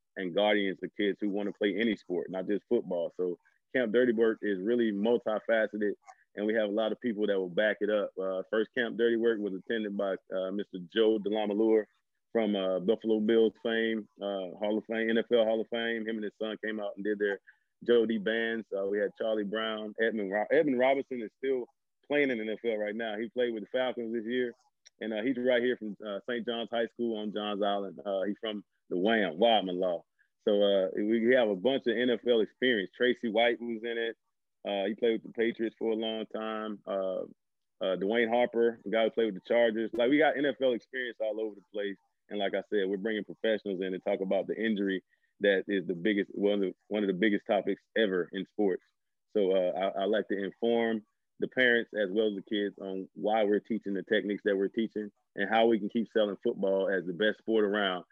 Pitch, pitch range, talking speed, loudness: 110 Hz, 100-115 Hz, 225 wpm, -31 LUFS